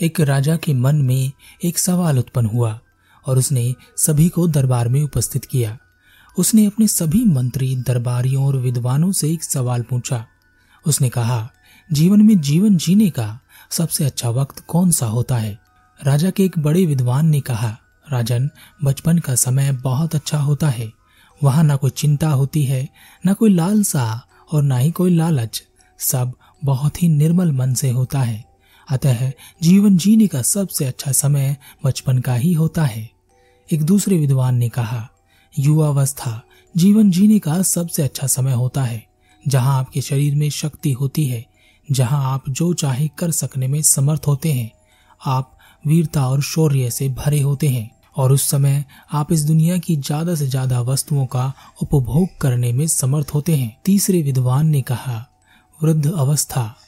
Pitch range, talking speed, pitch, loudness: 125-160 Hz, 160 wpm, 140 Hz, -18 LUFS